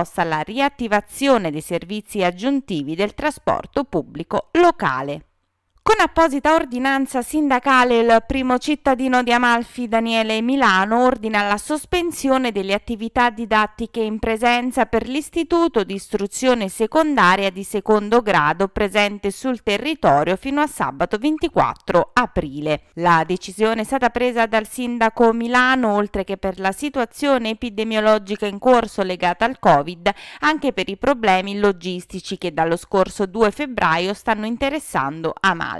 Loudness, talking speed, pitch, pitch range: -19 LUFS, 125 wpm, 225 Hz, 195-260 Hz